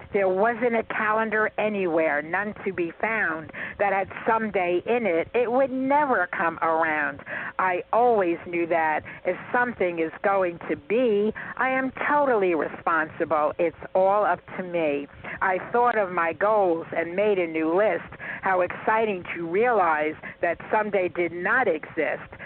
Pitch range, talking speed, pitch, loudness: 170-220 Hz, 150 wpm, 190 Hz, -24 LUFS